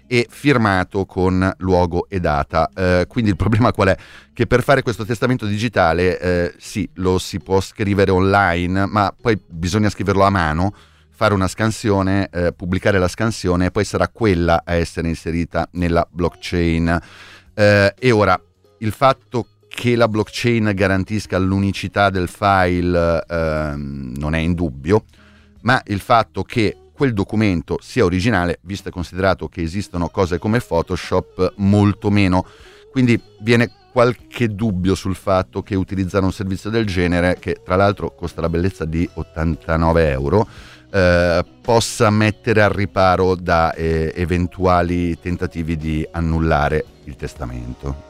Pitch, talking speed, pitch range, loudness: 95 Hz, 145 wpm, 85-105 Hz, -18 LUFS